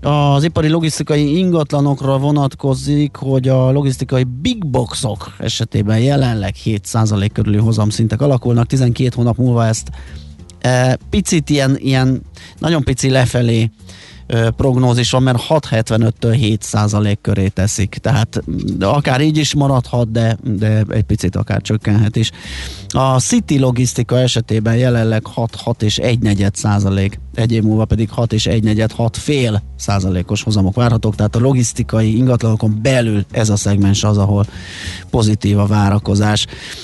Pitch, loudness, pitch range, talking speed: 115 Hz, -15 LUFS, 105-130 Hz, 135 wpm